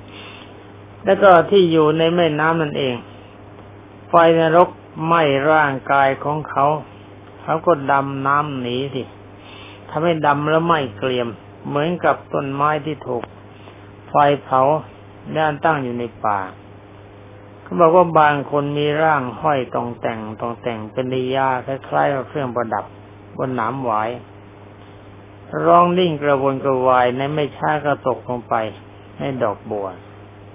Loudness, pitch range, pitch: -18 LUFS, 100-150 Hz, 125 Hz